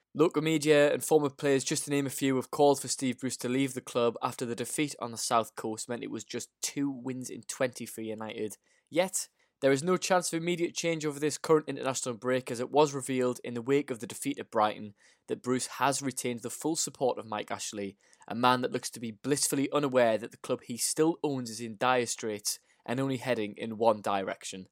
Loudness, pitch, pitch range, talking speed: -30 LUFS, 130 Hz, 120-145 Hz, 230 wpm